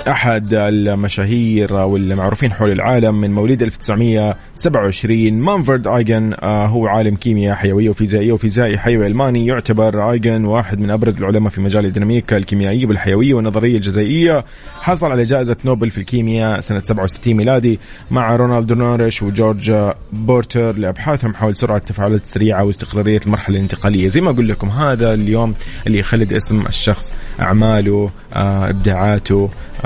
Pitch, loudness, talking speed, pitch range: 110 Hz, -15 LUFS, 130 wpm, 100-120 Hz